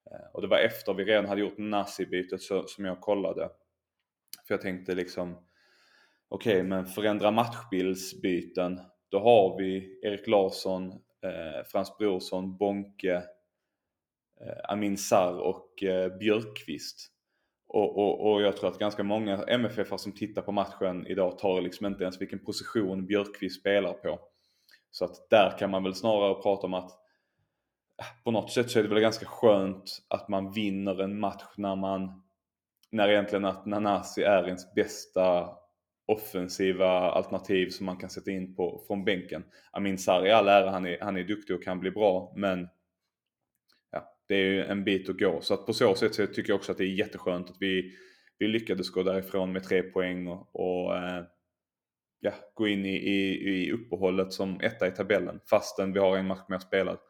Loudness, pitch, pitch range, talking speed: -29 LUFS, 95 Hz, 95-100 Hz, 175 wpm